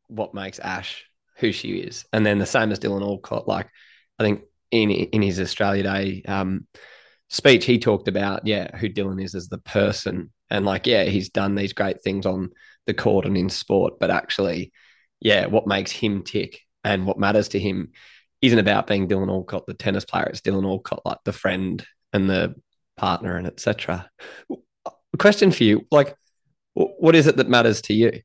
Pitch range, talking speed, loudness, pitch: 95-110 Hz, 190 wpm, -22 LUFS, 100 Hz